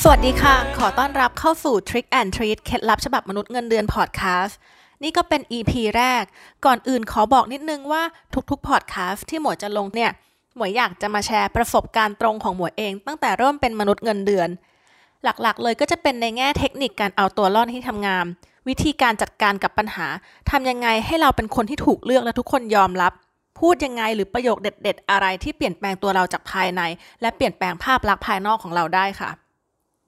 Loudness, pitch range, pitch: -21 LUFS, 200-260 Hz, 230 Hz